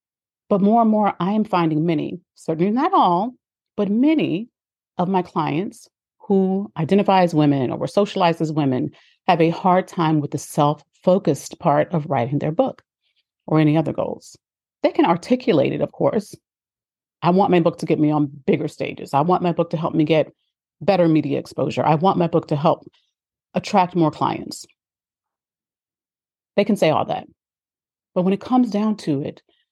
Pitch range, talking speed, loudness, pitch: 155-200 Hz, 180 wpm, -20 LUFS, 175 Hz